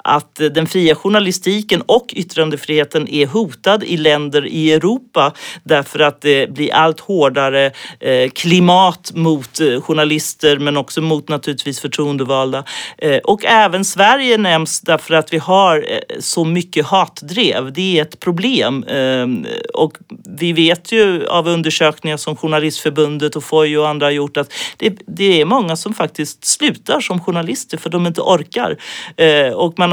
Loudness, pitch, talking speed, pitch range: -14 LUFS, 160 Hz, 140 wpm, 150-190 Hz